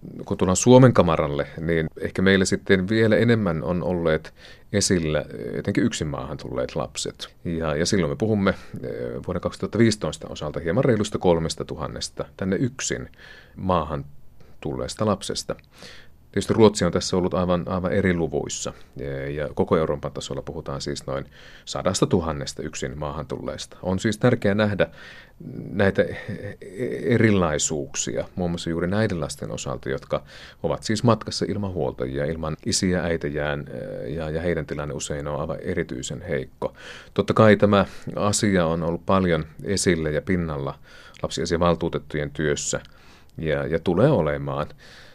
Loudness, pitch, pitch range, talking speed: -24 LUFS, 85 Hz, 75-100 Hz, 135 wpm